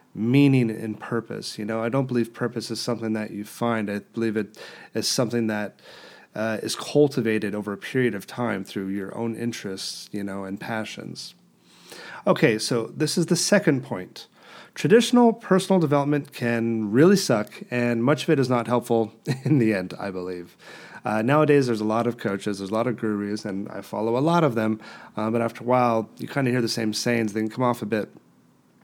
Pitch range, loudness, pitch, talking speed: 110-130 Hz, -24 LUFS, 115 Hz, 205 wpm